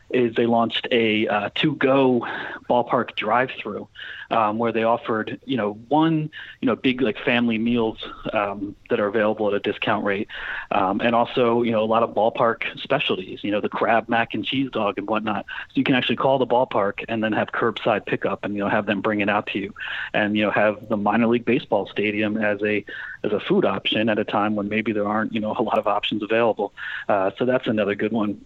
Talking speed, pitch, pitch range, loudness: 225 wpm, 115 Hz, 105-120 Hz, -22 LUFS